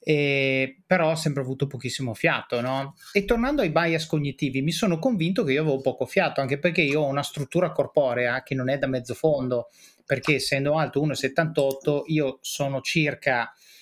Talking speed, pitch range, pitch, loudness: 180 wpm, 135-160 Hz, 140 Hz, -24 LUFS